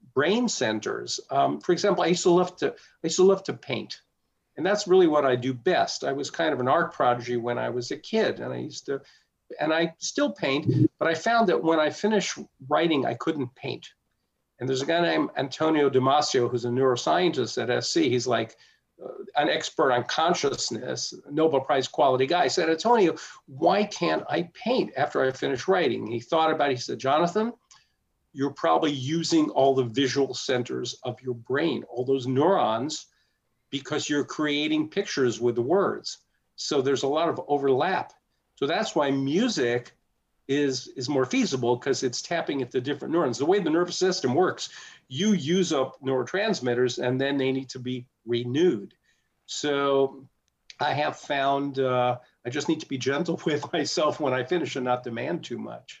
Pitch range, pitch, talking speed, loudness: 130-170 Hz, 140 Hz, 185 wpm, -25 LUFS